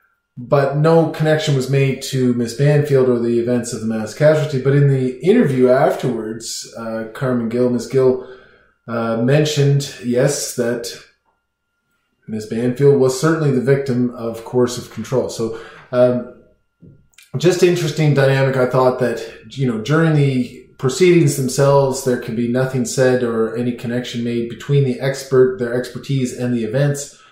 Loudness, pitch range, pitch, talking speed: -17 LUFS, 120-140 Hz, 130 Hz, 155 wpm